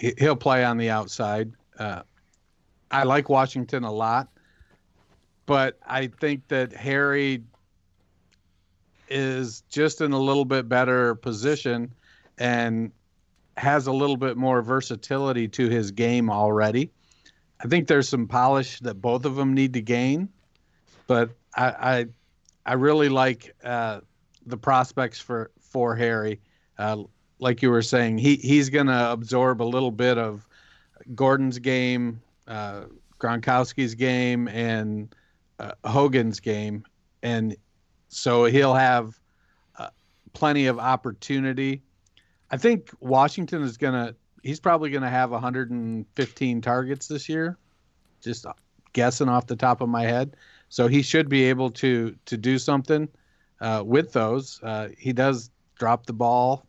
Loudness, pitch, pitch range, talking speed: -24 LUFS, 125 Hz, 115-135 Hz, 140 wpm